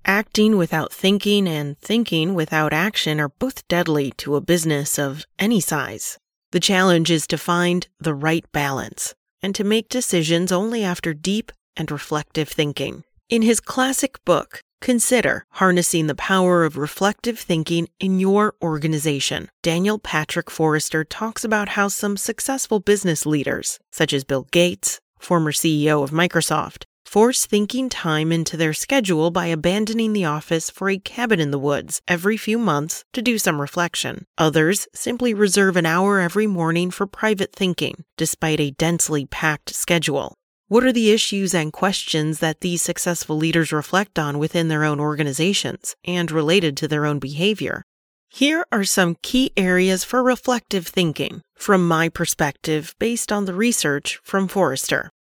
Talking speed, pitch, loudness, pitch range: 155 wpm, 175 Hz, -20 LUFS, 155-205 Hz